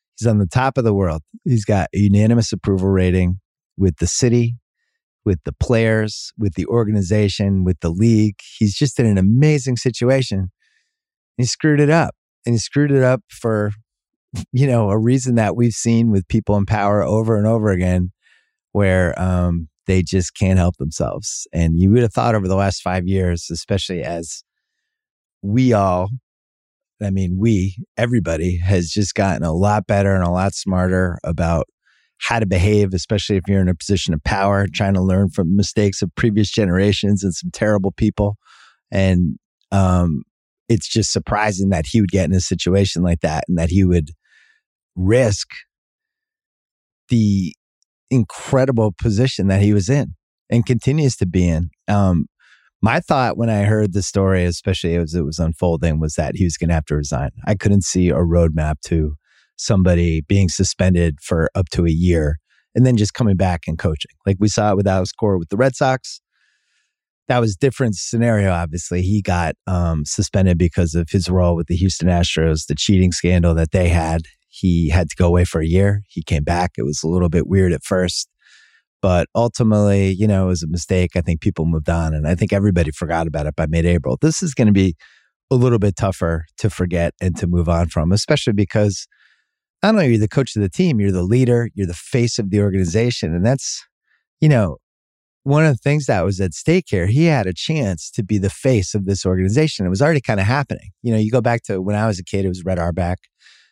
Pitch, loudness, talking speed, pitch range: 100 Hz, -18 LUFS, 200 wpm, 90-110 Hz